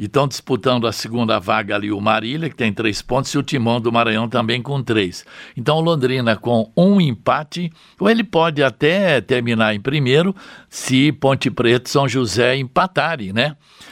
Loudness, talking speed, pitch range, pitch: -18 LUFS, 175 wpm, 115-150 Hz, 130 Hz